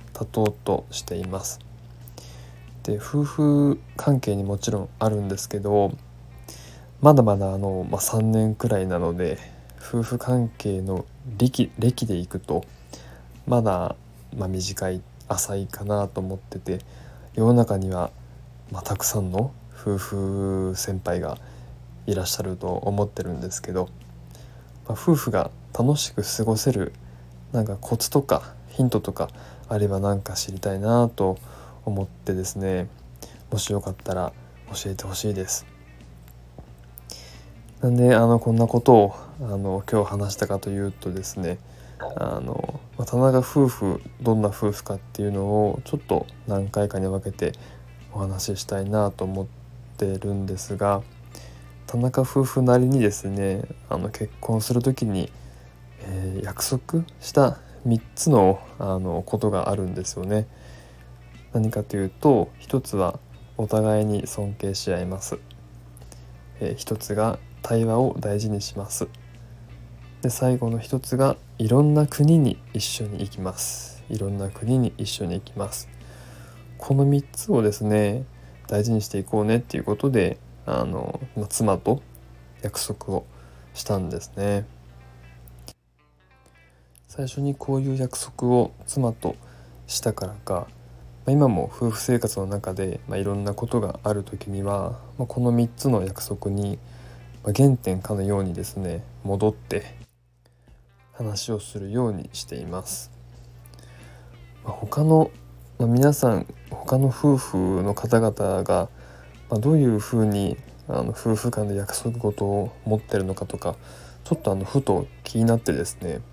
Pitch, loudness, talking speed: 100 Hz, -24 LUFS, 260 characters per minute